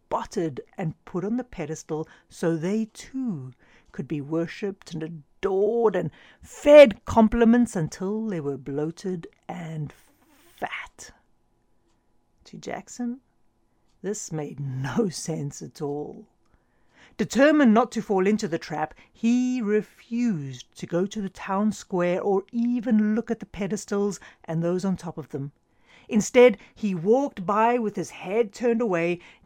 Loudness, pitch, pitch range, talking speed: -24 LUFS, 195 Hz, 165-225 Hz, 135 wpm